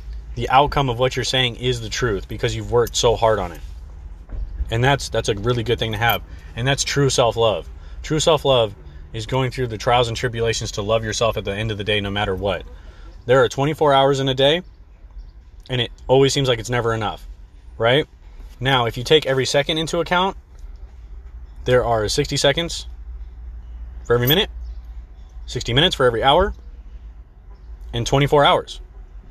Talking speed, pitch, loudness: 180 wpm, 110 Hz, -19 LUFS